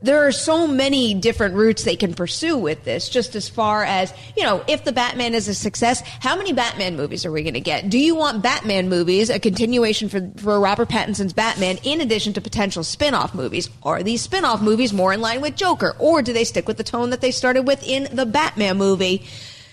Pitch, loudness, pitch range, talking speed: 220 Hz, -19 LUFS, 195-260 Hz, 225 wpm